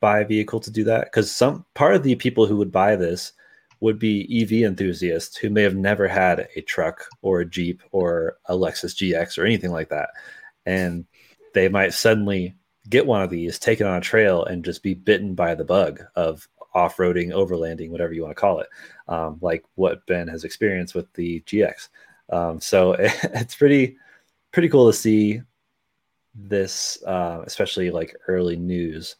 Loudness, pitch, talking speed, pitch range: -21 LUFS, 95 Hz, 185 wpm, 85-110 Hz